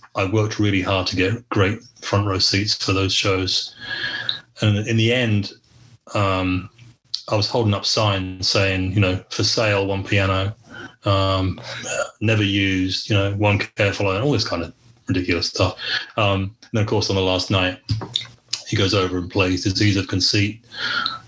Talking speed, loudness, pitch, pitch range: 170 wpm, -20 LUFS, 100 Hz, 95-110 Hz